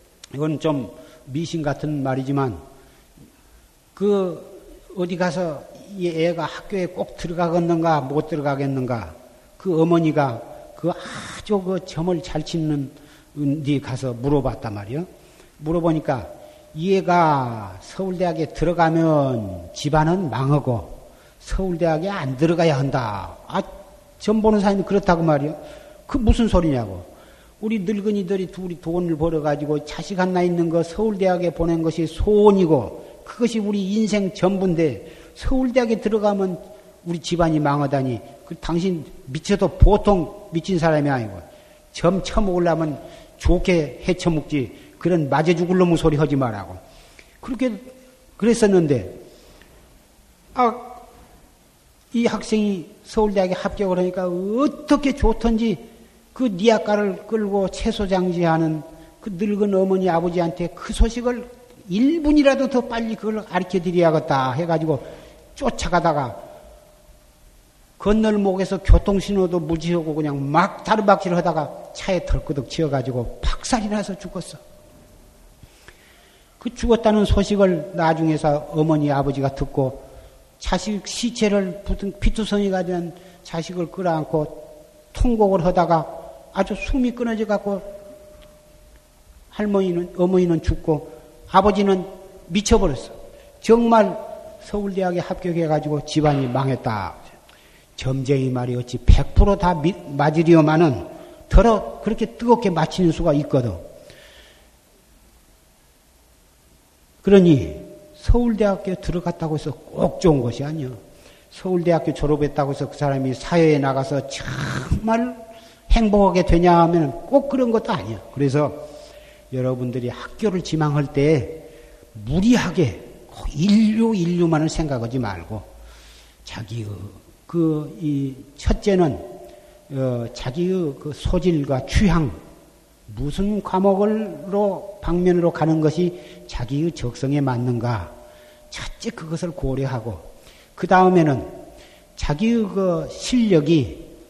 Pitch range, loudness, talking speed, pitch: 145-200 Hz, -21 LUFS, 260 characters per minute, 170 Hz